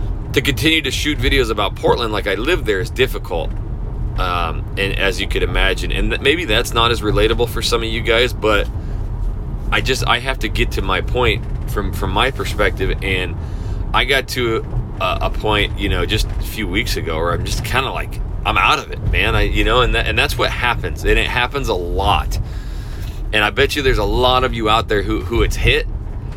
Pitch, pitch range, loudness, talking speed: 105 Hz, 100-120 Hz, -18 LUFS, 225 wpm